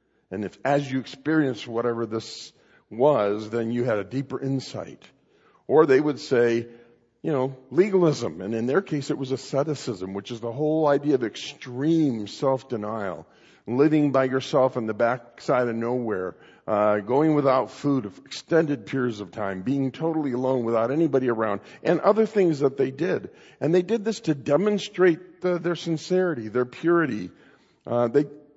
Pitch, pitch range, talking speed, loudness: 135 Hz, 120-155 Hz, 165 wpm, -24 LUFS